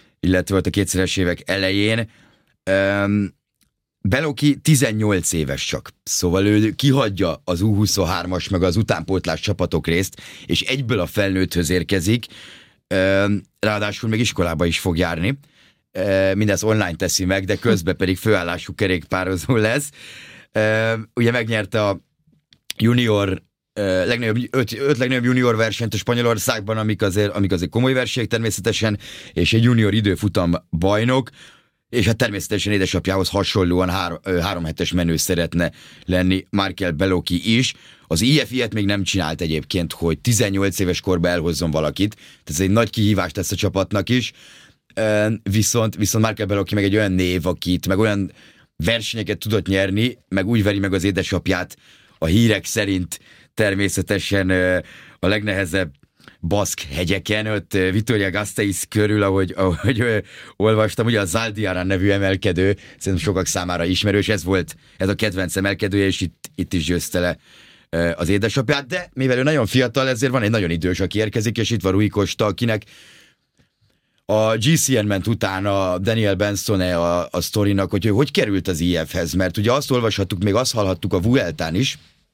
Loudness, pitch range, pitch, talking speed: -20 LUFS, 90-110 Hz, 100 Hz, 150 wpm